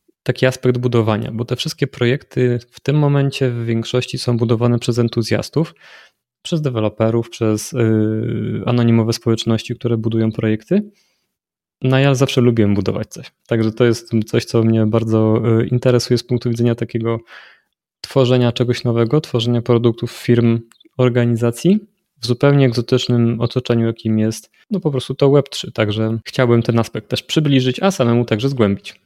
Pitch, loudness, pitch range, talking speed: 120 Hz, -17 LUFS, 115-130 Hz, 145 wpm